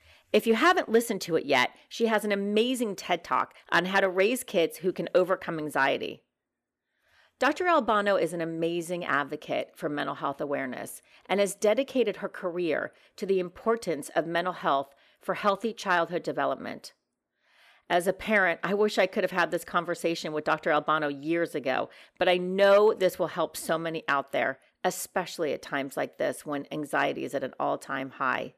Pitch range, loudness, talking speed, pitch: 160-205 Hz, -28 LUFS, 180 wpm, 180 Hz